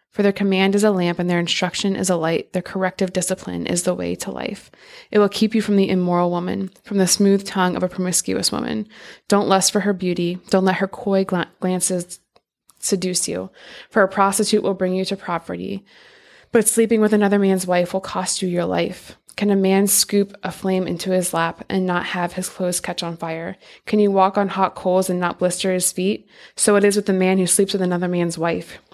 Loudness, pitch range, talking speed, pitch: -20 LUFS, 180-200 Hz, 225 wpm, 185 Hz